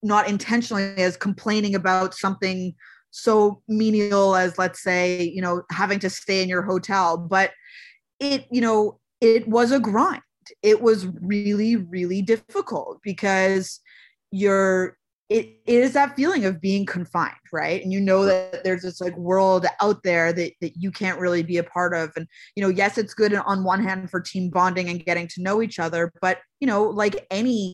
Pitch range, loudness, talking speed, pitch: 185-215 Hz, -22 LUFS, 185 wpm, 195 Hz